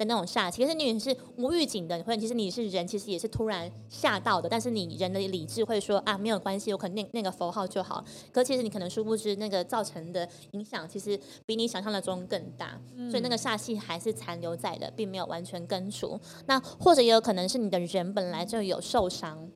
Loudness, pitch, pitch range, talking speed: -30 LUFS, 205 Hz, 180-225 Hz, 345 characters per minute